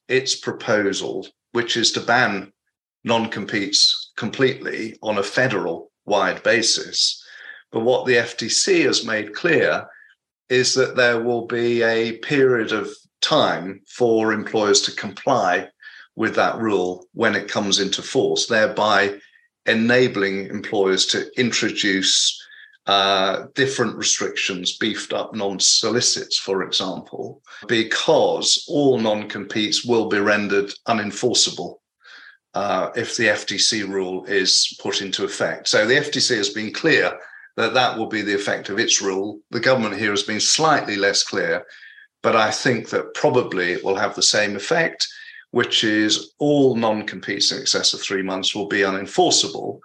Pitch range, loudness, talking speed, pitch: 100-125 Hz, -19 LUFS, 145 wpm, 105 Hz